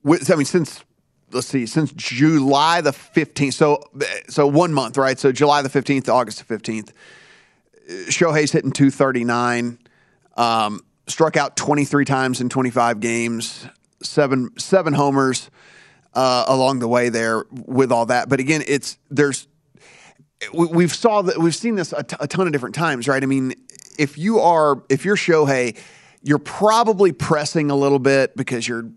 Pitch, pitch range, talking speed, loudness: 140 Hz, 130-160 Hz, 170 wpm, -18 LUFS